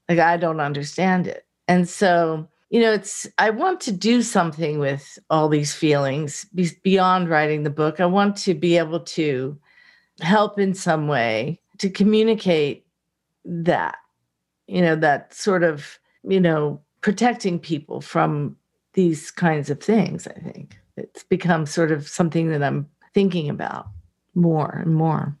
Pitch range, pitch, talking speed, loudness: 150-185 Hz, 170 Hz, 155 wpm, -21 LUFS